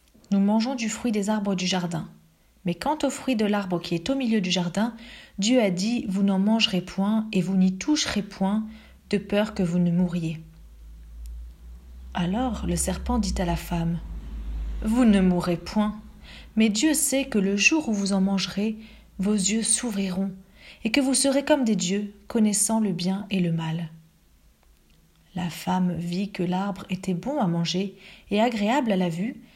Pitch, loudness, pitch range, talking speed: 195 Hz, -25 LUFS, 175-220 Hz, 175 wpm